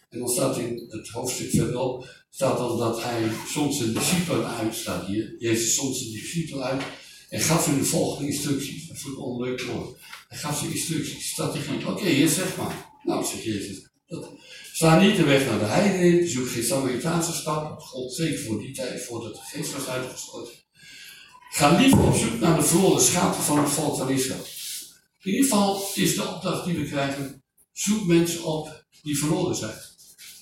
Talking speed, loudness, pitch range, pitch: 185 wpm, -24 LUFS, 125-170 Hz, 145 Hz